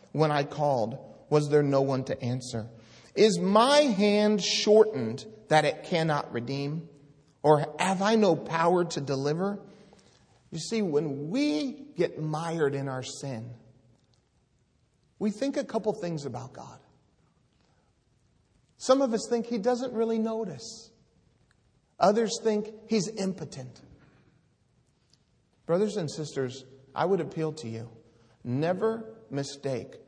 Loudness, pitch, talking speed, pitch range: -28 LUFS, 155 Hz, 125 wpm, 135-210 Hz